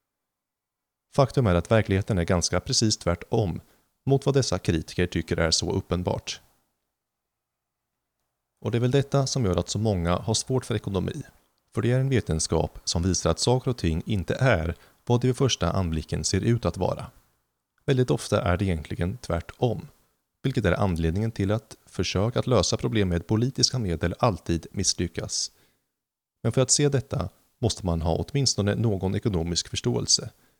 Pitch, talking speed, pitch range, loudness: 100 Hz, 165 wpm, 85-125 Hz, -25 LUFS